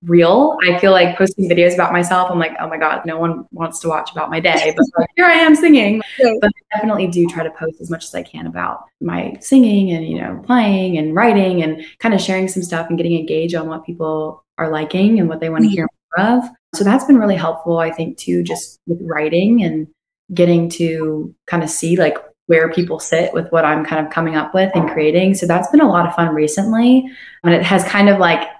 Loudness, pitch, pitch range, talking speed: -15 LUFS, 170 Hz, 160-195 Hz, 240 wpm